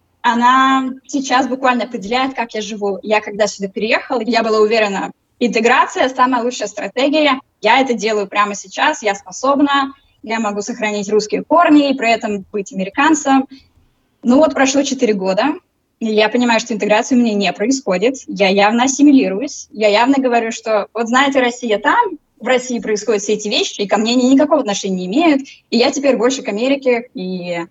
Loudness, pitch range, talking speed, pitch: -15 LUFS, 210-270 Hz, 175 wpm, 240 Hz